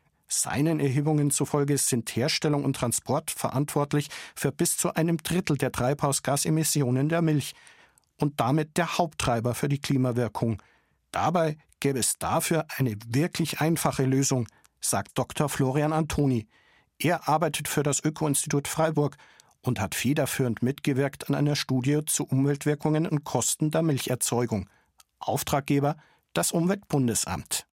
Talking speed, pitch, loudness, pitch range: 130 wpm, 145 Hz, -26 LUFS, 135-155 Hz